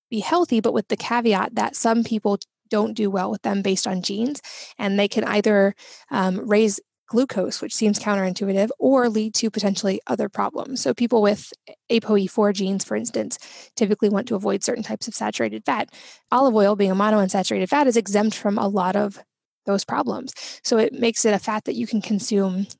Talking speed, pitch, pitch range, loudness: 190 wpm, 210 Hz, 200-230 Hz, -22 LUFS